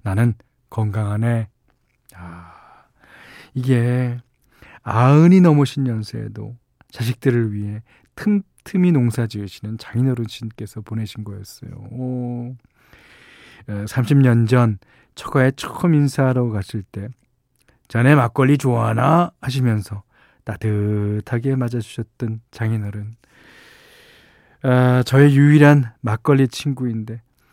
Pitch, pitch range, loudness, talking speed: 120 Hz, 110-130 Hz, -18 LUFS, 225 characters per minute